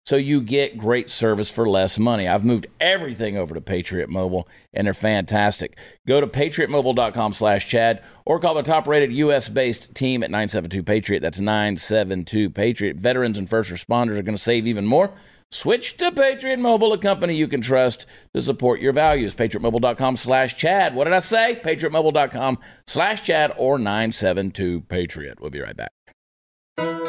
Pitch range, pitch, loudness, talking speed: 100-145 Hz, 115 Hz, -20 LUFS, 160 wpm